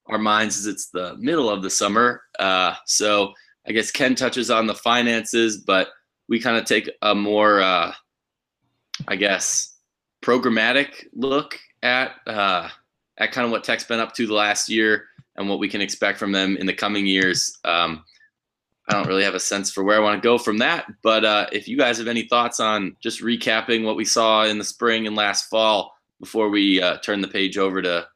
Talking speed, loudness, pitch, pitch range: 205 wpm, -20 LUFS, 105 Hz, 100-115 Hz